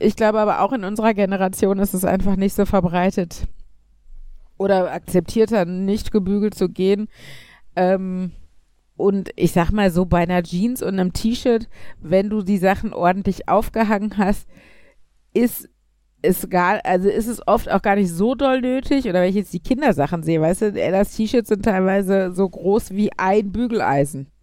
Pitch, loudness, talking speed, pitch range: 195 Hz, -19 LUFS, 170 wpm, 180-215 Hz